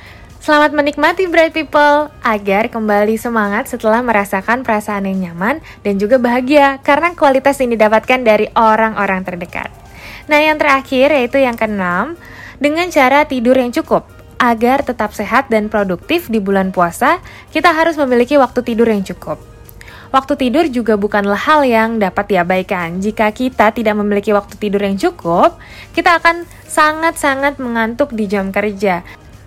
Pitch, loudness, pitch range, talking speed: 230 Hz, -13 LUFS, 205-285 Hz, 145 wpm